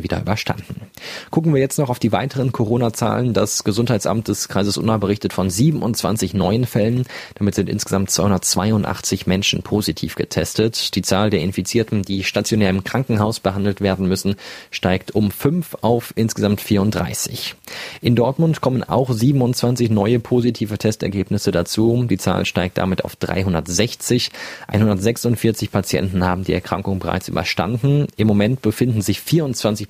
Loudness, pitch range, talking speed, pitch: -19 LUFS, 95-120 Hz, 145 wpm, 105 Hz